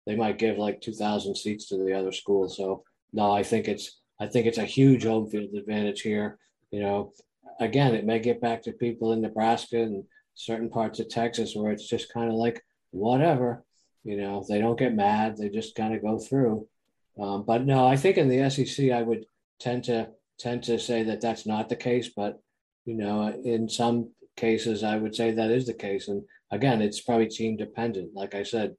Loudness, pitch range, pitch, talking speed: -27 LUFS, 105-120 Hz, 115 Hz, 215 wpm